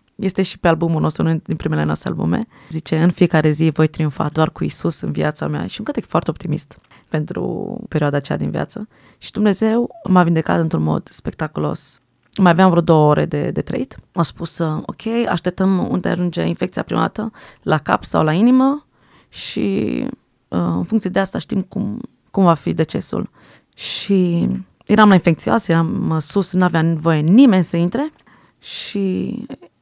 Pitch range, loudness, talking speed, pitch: 155-200 Hz, -18 LUFS, 170 wpm, 170 Hz